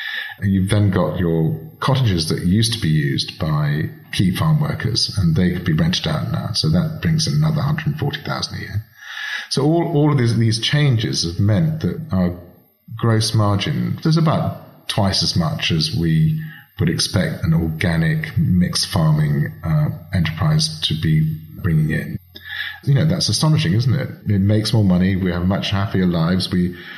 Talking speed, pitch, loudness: 190 wpm, 110 Hz, -19 LUFS